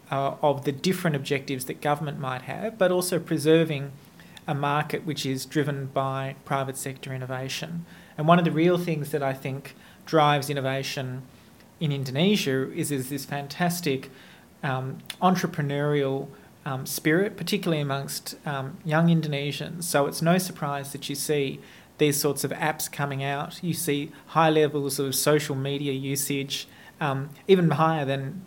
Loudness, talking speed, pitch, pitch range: -26 LUFS, 150 wpm, 145 Hz, 135-160 Hz